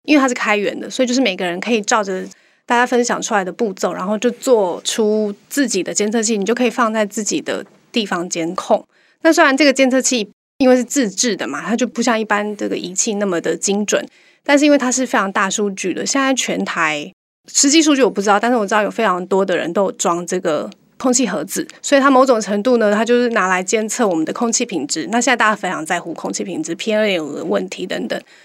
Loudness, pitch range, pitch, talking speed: -17 LUFS, 200-255 Hz, 225 Hz, 360 characters per minute